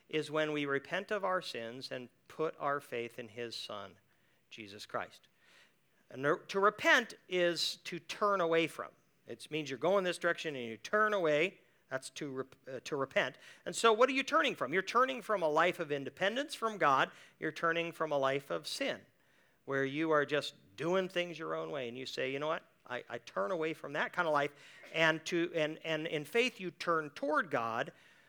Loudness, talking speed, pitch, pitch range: -34 LUFS, 205 wpm, 160 Hz, 140-180 Hz